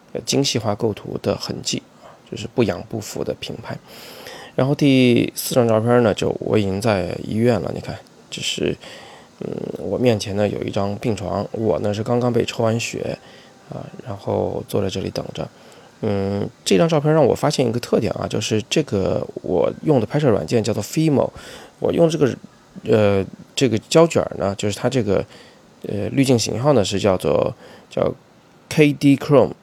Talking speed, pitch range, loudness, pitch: 265 characters per minute, 105-135 Hz, -20 LUFS, 115 Hz